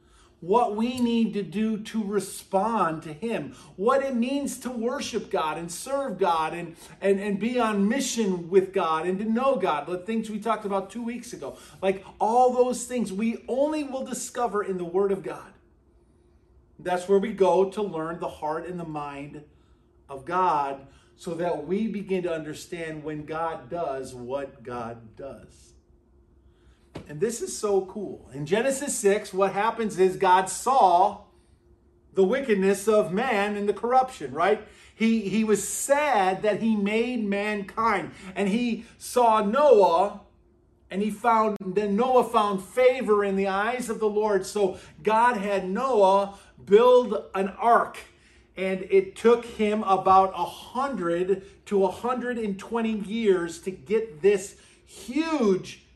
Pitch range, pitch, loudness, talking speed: 185-225 Hz, 200 Hz, -25 LUFS, 155 wpm